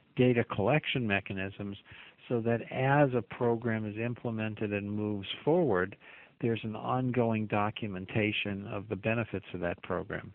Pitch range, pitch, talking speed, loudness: 100-120 Hz, 110 Hz, 135 wpm, -32 LUFS